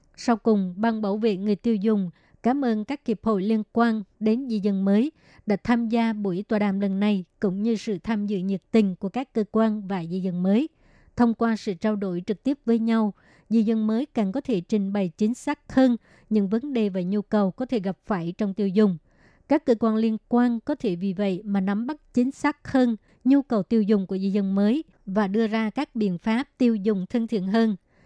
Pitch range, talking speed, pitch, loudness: 200-230 Hz, 235 wpm, 220 Hz, -24 LUFS